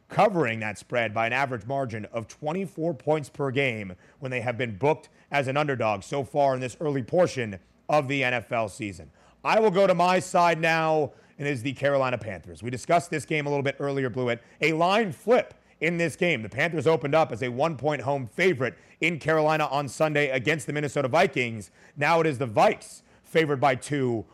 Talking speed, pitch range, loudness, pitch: 205 wpm, 125-155 Hz, -25 LUFS, 140 Hz